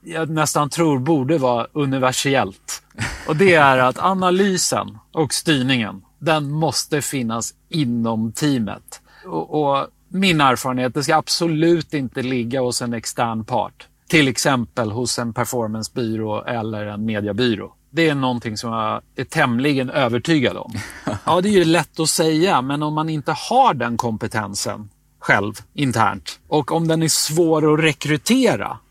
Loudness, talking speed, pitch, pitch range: -19 LUFS, 150 wpm, 135 Hz, 120-160 Hz